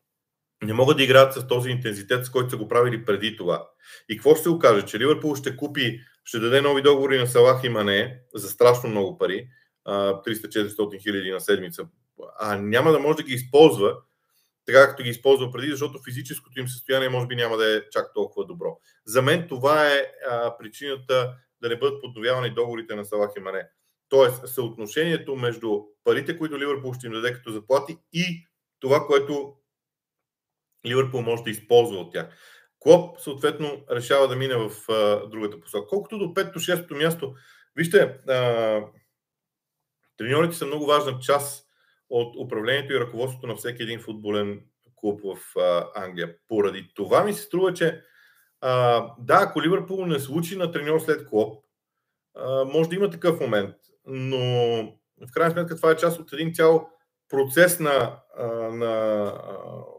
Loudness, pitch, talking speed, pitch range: -23 LUFS, 130 Hz, 165 wpm, 115-155 Hz